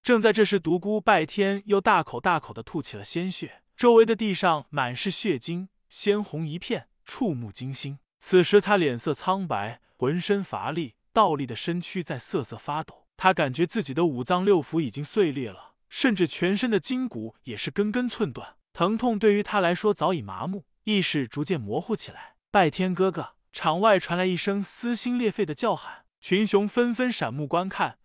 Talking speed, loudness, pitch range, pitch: 280 characters per minute, -25 LUFS, 155-210 Hz, 185 Hz